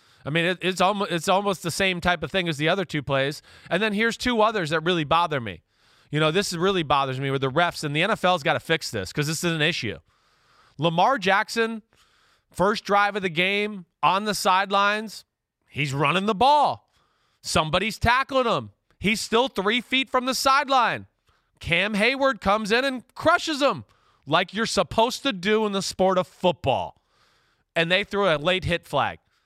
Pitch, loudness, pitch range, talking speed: 185 Hz, -23 LUFS, 165-215 Hz, 185 wpm